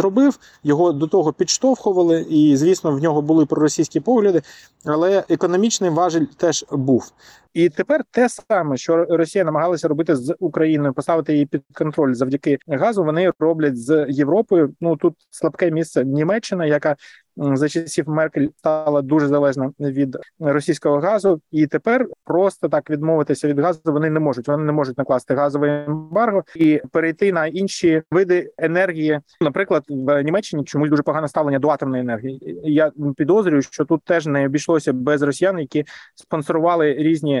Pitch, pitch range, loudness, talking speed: 155 Hz, 145-170 Hz, -19 LUFS, 155 wpm